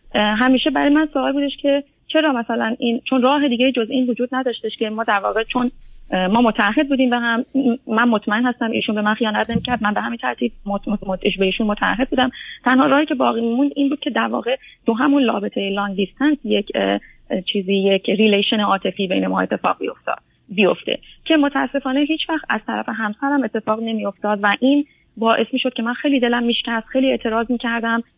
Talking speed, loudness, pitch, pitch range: 200 wpm, -19 LUFS, 235 Hz, 210-265 Hz